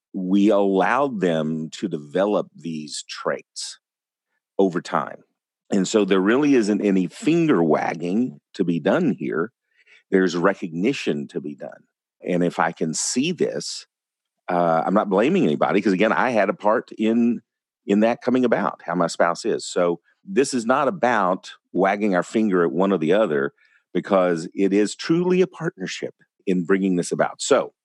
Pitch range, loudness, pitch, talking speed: 85-105 Hz, -21 LUFS, 95 Hz, 165 wpm